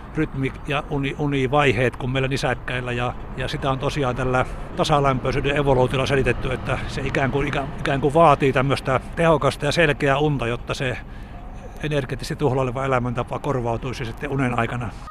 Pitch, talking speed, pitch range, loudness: 135 Hz, 145 wpm, 125-145 Hz, -22 LUFS